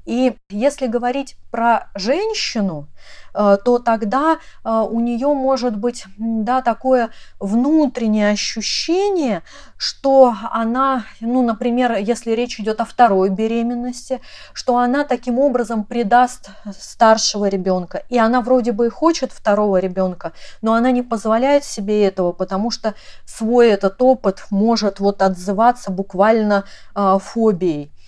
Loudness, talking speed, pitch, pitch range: -17 LUFS, 120 wpm, 230 Hz, 205-250 Hz